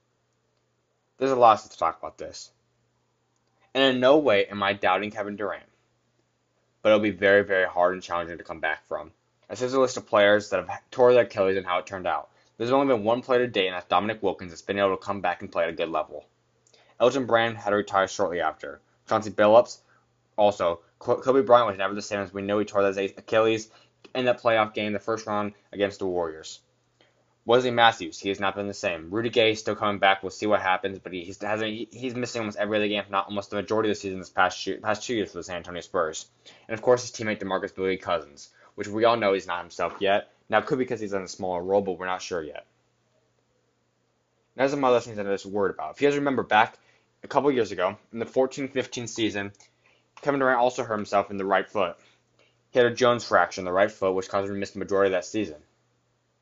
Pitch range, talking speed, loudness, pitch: 95-115 Hz, 240 wpm, -25 LUFS, 105 Hz